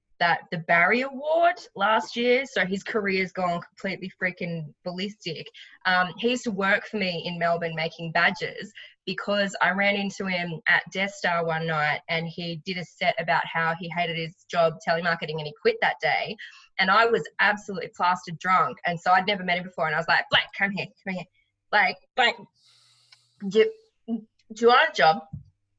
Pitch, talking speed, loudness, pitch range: 180 Hz, 190 wpm, -25 LUFS, 165-205 Hz